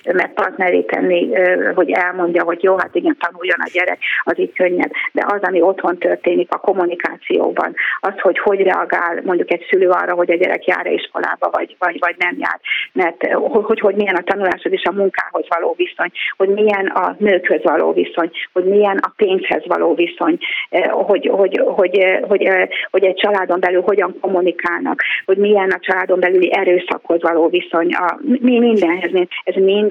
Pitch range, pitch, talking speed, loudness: 180-210 Hz, 190 Hz, 170 wpm, -16 LUFS